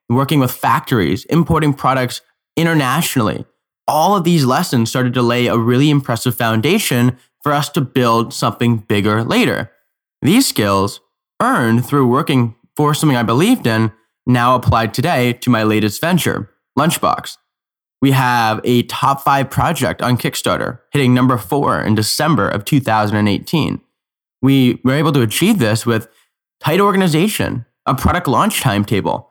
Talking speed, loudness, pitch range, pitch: 145 wpm, -15 LUFS, 115-145 Hz, 125 Hz